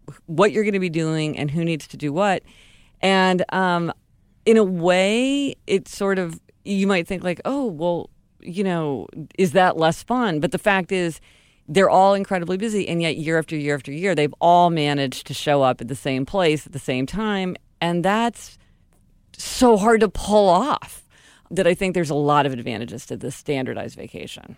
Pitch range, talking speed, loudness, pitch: 150-195 Hz, 195 wpm, -21 LUFS, 175 Hz